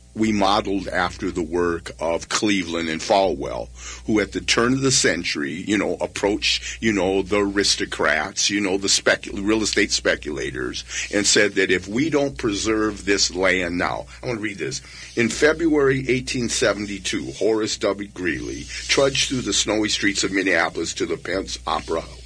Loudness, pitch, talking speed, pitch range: -21 LUFS, 100 Hz, 170 wpm, 95-115 Hz